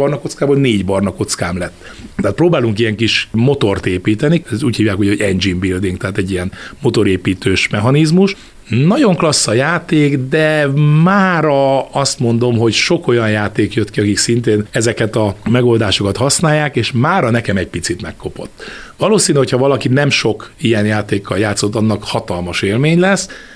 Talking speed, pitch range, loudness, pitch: 155 wpm, 105-145 Hz, -14 LUFS, 115 Hz